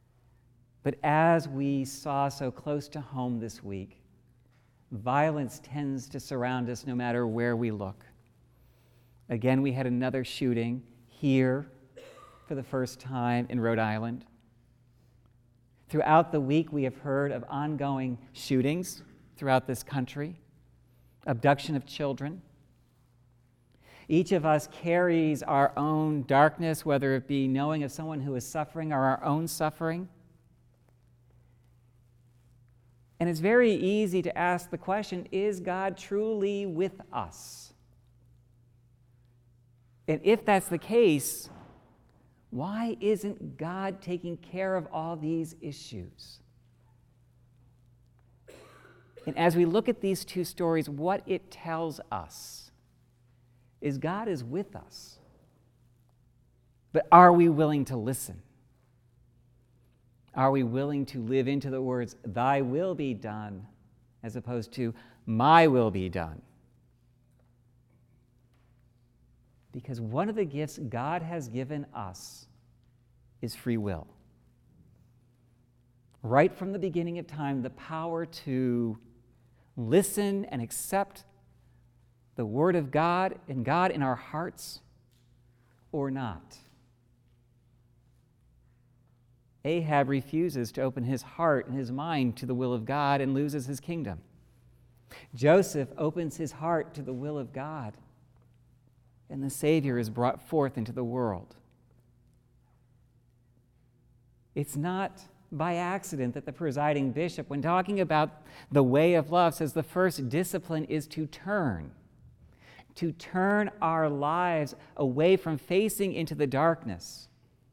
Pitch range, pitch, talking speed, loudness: 120-155 Hz, 130 Hz, 120 wpm, -29 LUFS